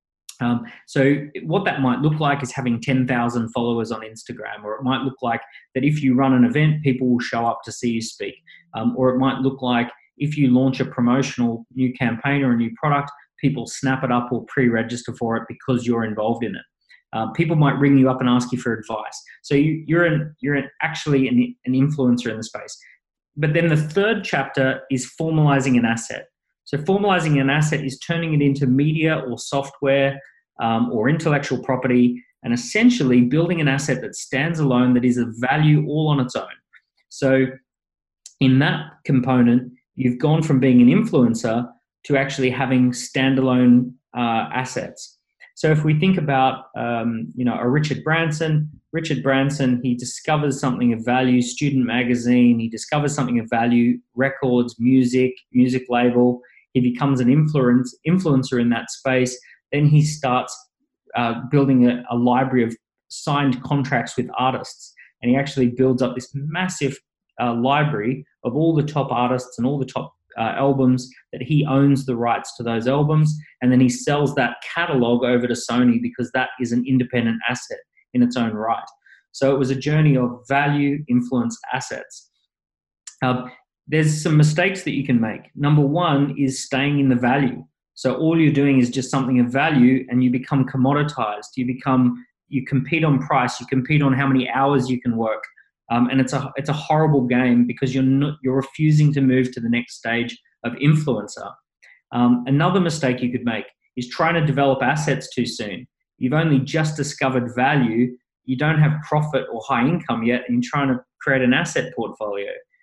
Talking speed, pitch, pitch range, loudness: 185 wpm, 130 Hz, 125-145 Hz, -20 LUFS